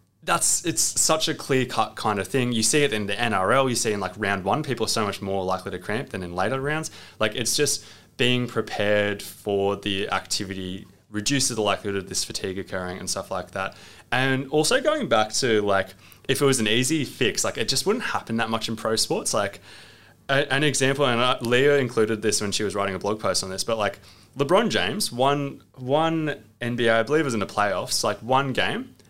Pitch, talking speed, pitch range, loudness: 110 Hz, 220 wpm, 100-135 Hz, -23 LUFS